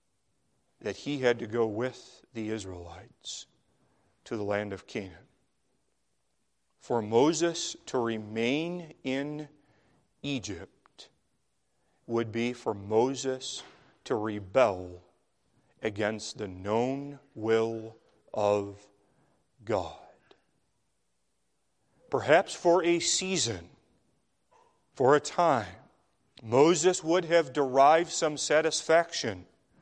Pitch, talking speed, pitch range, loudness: 115 Hz, 90 wpm, 105-150 Hz, -29 LUFS